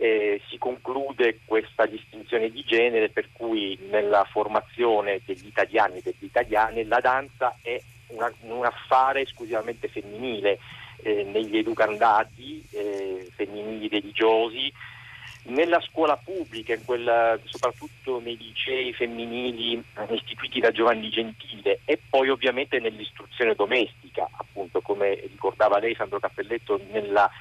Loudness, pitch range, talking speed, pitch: -25 LUFS, 110-140 Hz, 120 wpm, 120 Hz